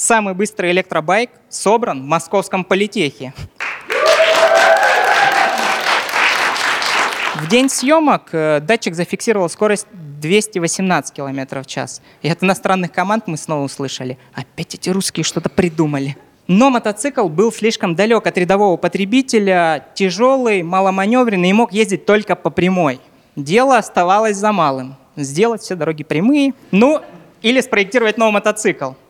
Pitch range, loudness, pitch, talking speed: 160-225 Hz, -15 LUFS, 195 Hz, 120 wpm